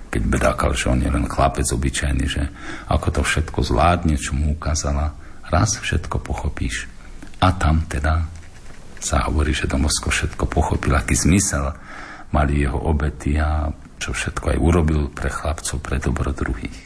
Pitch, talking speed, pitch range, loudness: 75 Hz, 155 wpm, 70-80 Hz, -21 LUFS